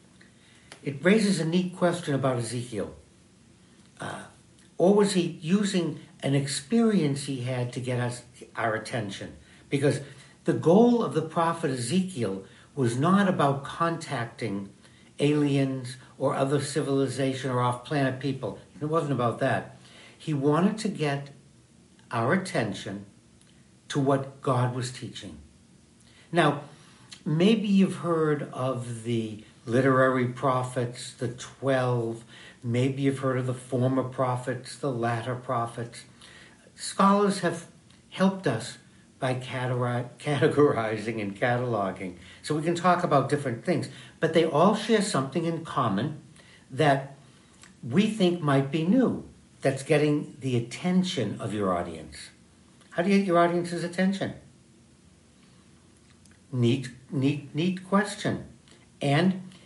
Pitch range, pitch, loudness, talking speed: 120-165 Hz, 135 Hz, -27 LUFS, 120 wpm